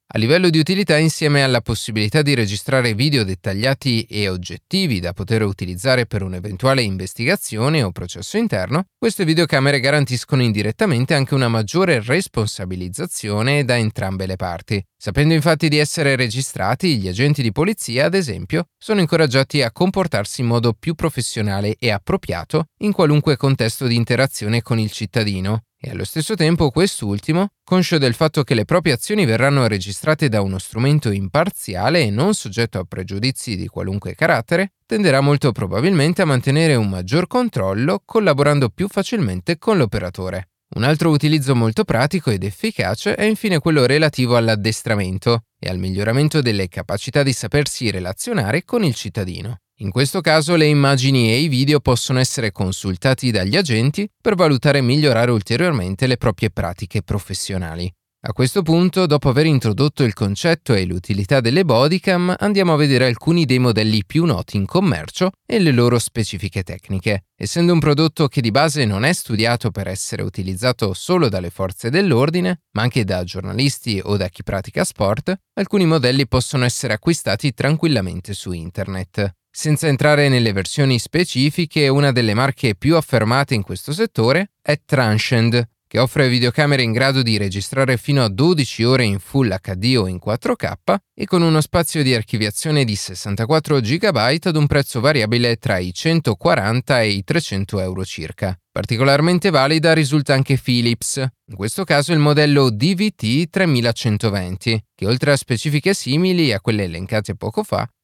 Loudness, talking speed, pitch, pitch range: -18 LUFS, 155 wpm, 130 Hz, 105-155 Hz